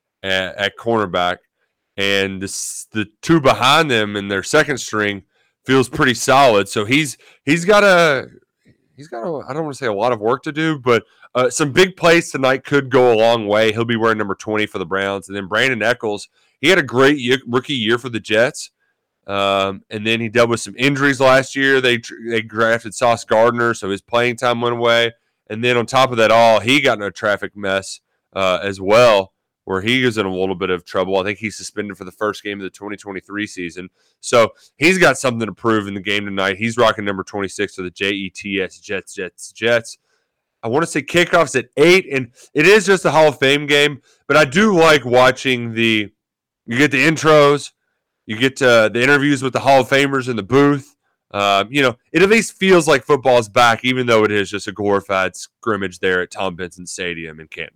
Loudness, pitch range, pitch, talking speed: -16 LUFS, 100-135 Hz, 115 Hz, 215 wpm